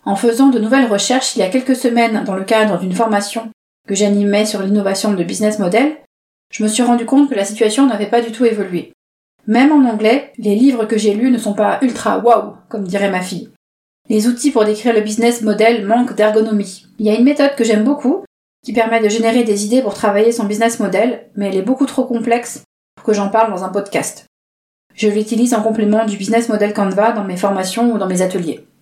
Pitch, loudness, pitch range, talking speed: 220 Hz, -15 LUFS, 205-235 Hz, 225 wpm